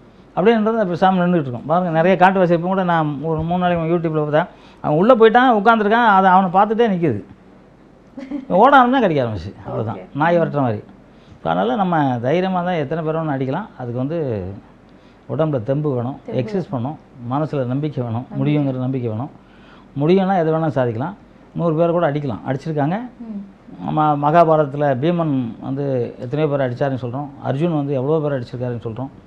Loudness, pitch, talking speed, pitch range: -18 LUFS, 155 Hz, 150 wpm, 135-180 Hz